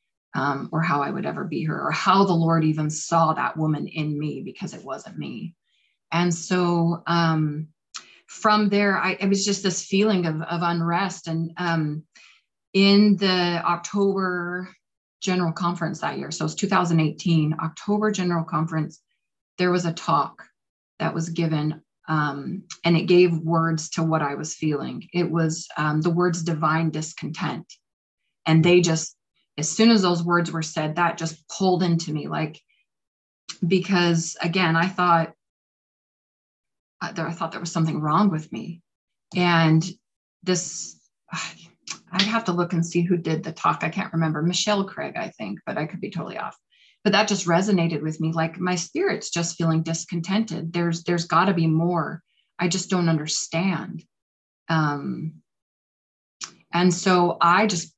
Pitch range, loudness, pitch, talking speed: 160-180 Hz, -23 LUFS, 170 Hz, 165 wpm